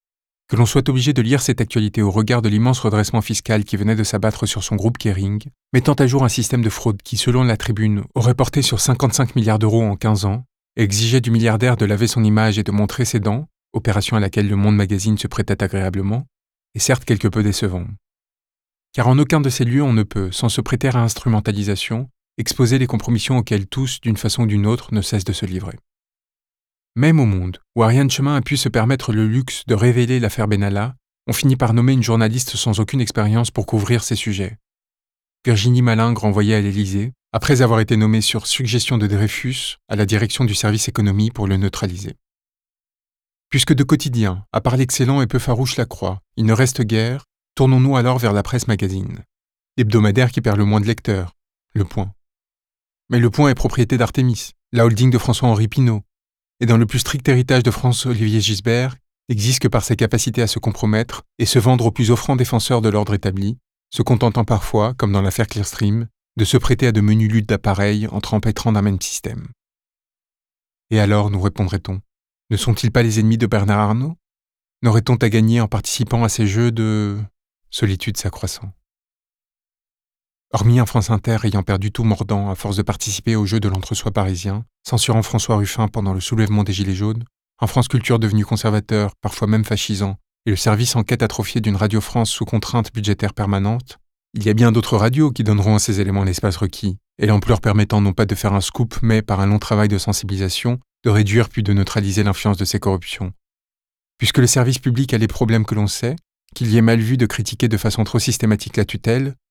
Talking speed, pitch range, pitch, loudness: 205 wpm, 105-120 Hz, 110 Hz, -18 LUFS